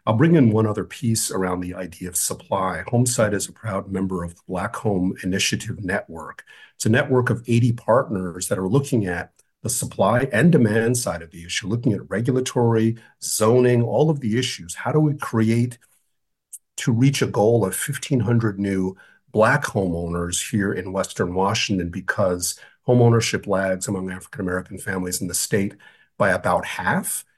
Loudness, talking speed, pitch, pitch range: -21 LUFS, 170 wpm, 110 Hz, 95-120 Hz